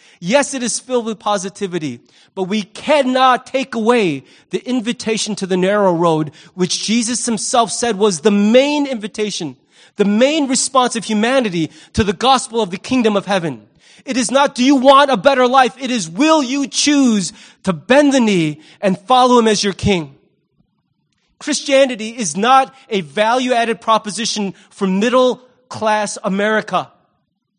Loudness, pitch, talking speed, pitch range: -15 LUFS, 220 Hz, 160 wpm, 195-255 Hz